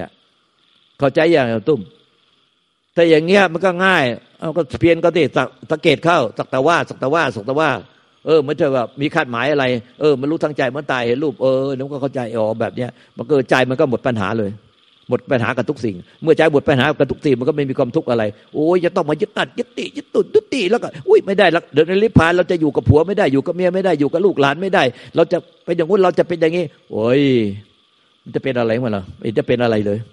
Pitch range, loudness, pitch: 125-170 Hz, -17 LUFS, 150 Hz